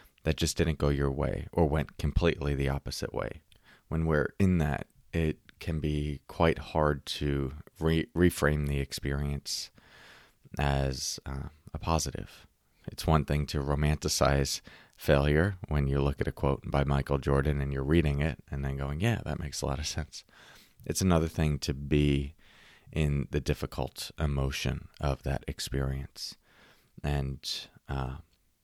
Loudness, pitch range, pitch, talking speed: -31 LUFS, 70-80 Hz, 75 Hz, 155 wpm